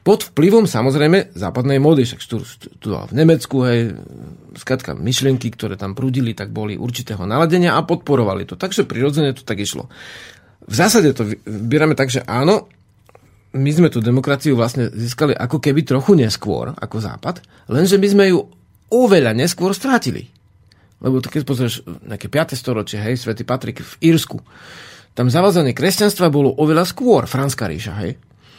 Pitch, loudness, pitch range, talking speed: 130 Hz, -17 LUFS, 115-160 Hz, 160 wpm